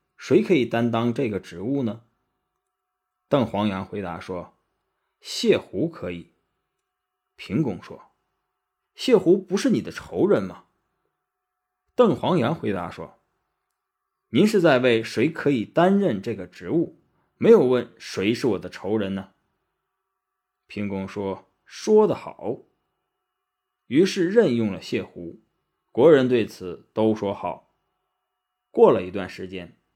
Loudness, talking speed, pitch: -22 LUFS, 175 characters per minute, 115 Hz